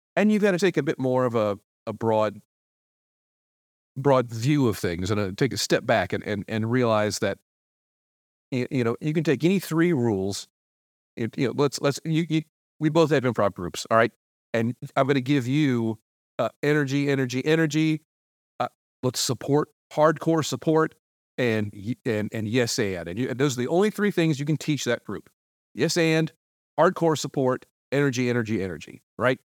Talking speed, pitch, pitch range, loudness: 185 wpm, 130 Hz, 110-155 Hz, -25 LUFS